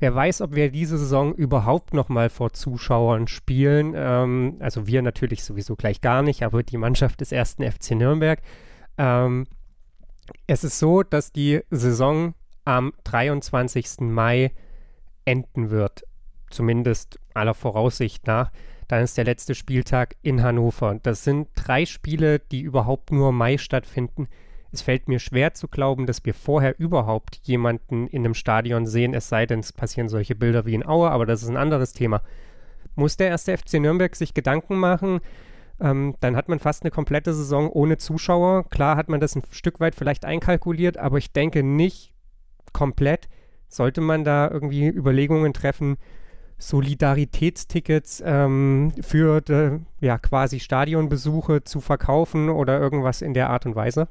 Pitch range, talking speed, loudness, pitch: 120-150 Hz, 155 wpm, -22 LUFS, 135 Hz